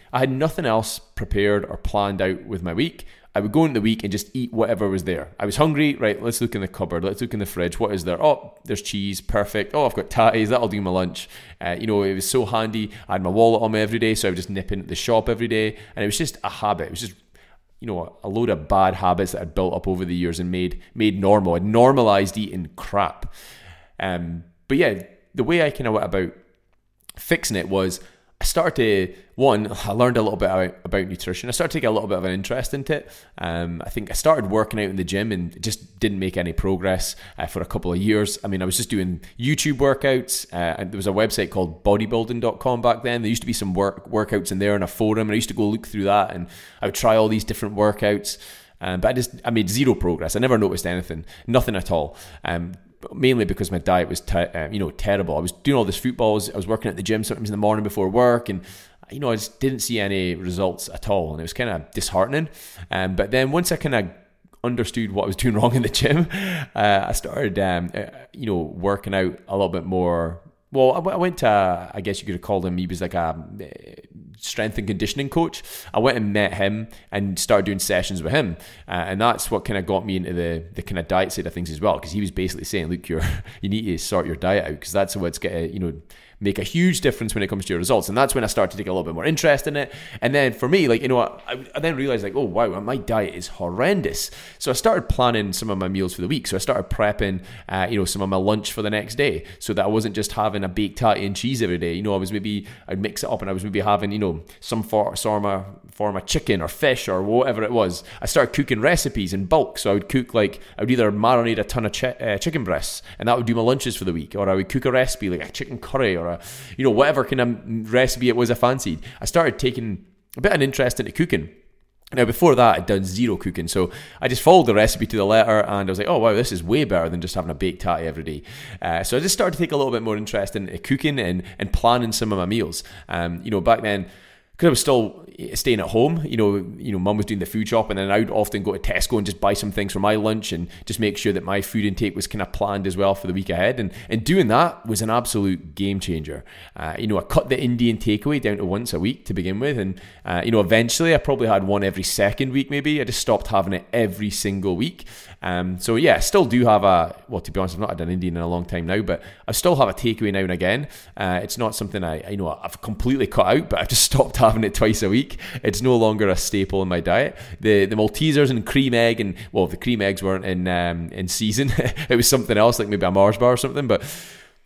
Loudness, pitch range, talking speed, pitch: -22 LUFS, 95-115 Hz, 275 wpm, 100 Hz